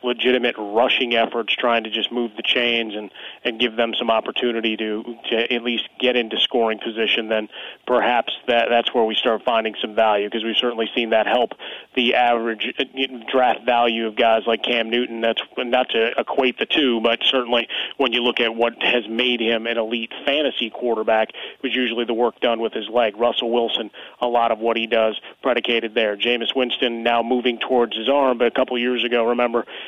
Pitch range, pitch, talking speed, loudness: 115-125 Hz, 120 Hz, 200 wpm, -20 LUFS